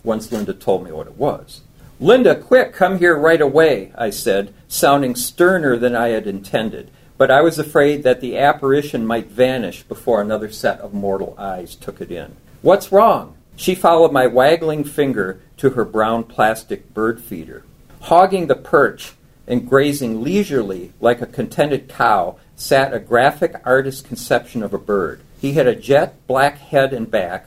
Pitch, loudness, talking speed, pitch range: 130 Hz, -16 LUFS, 170 wpm, 115-150 Hz